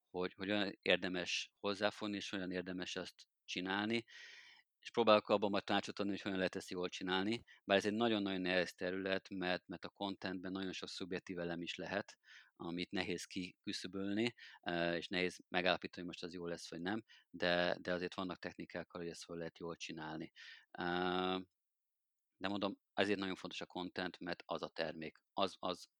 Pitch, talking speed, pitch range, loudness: 95 Hz, 170 wpm, 90-100 Hz, -40 LUFS